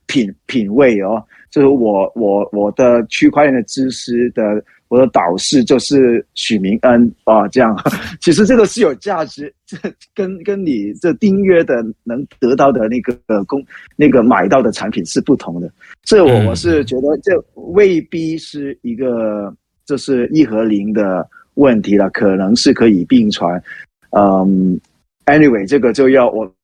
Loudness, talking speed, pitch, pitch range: -13 LUFS, 235 characters per minute, 125 Hz, 105-150 Hz